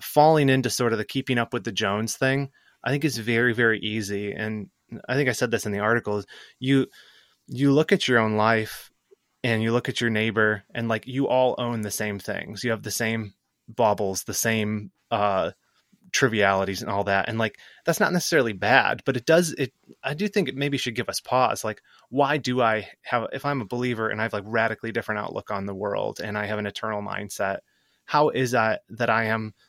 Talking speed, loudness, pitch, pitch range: 220 wpm, -24 LUFS, 115 Hz, 105-130 Hz